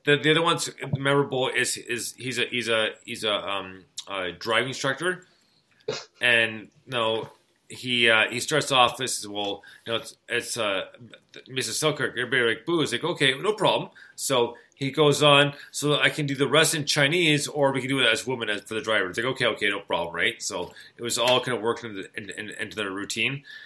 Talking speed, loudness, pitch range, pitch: 220 wpm, -24 LUFS, 115-145 Hz, 130 Hz